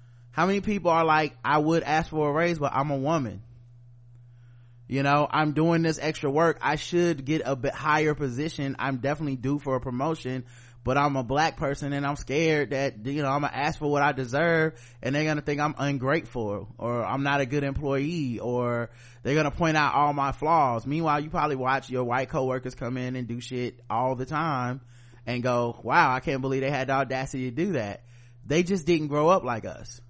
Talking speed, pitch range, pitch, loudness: 220 wpm, 125-150 Hz, 140 Hz, -26 LUFS